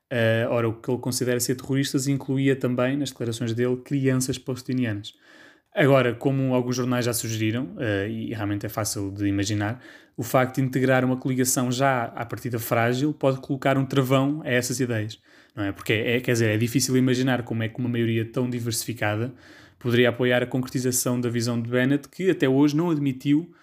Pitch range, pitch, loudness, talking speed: 115-135 Hz, 125 Hz, -24 LUFS, 190 wpm